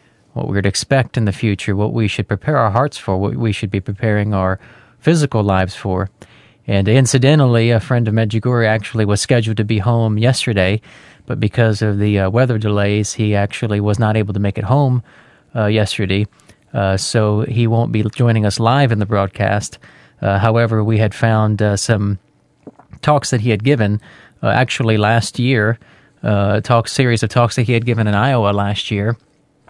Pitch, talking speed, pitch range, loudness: 110 Hz, 190 wpm, 105-120 Hz, -16 LUFS